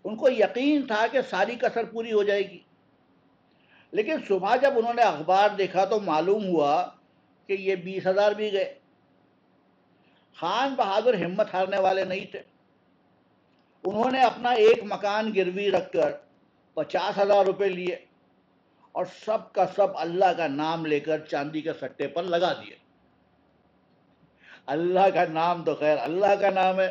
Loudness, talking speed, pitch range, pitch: -25 LUFS, 155 wpm, 180-215 Hz, 195 Hz